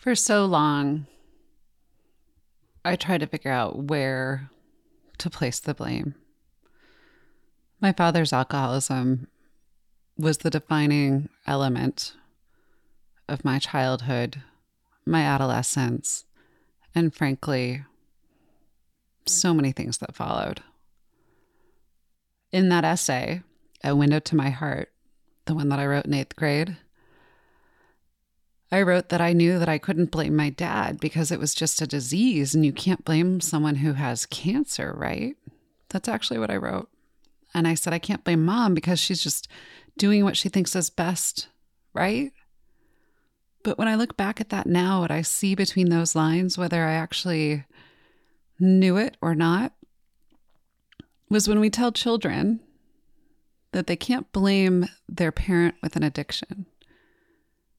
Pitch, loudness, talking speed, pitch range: 170 Hz, -24 LUFS, 135 wpm, 145-200 Hz